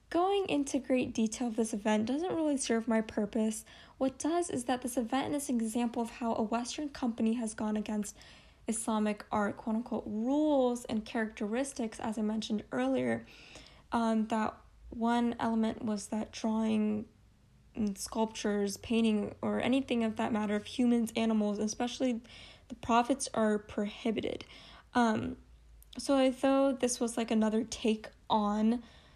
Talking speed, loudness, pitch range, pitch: 150 wpm, -33 LUFS, 215-250 Hz, 230 Hz